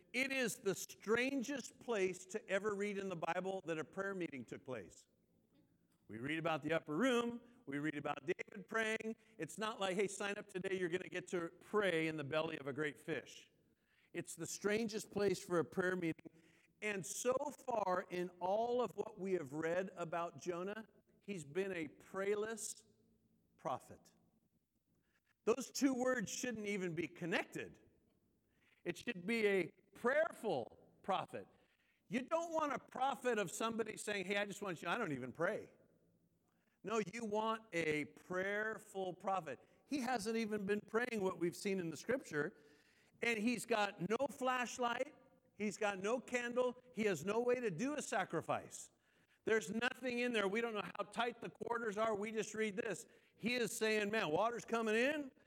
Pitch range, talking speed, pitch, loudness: 180-230 Hz, 175 wpm, 205 Hz, -41 LUFS